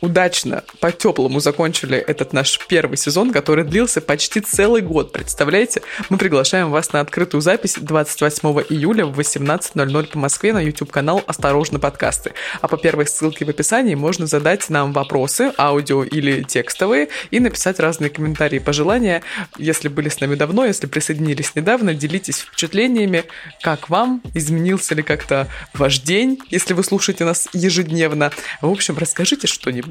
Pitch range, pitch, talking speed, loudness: 145-185 Hz, 155 Hz, 150 wpm, -17 LUFS